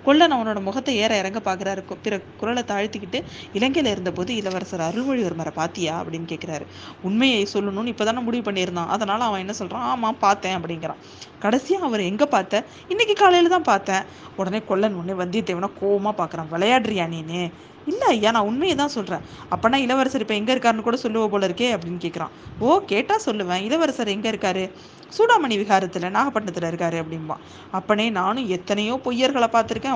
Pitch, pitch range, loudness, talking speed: 205 Hz, 185-240 Hz, -22 LUFS, 160 wpm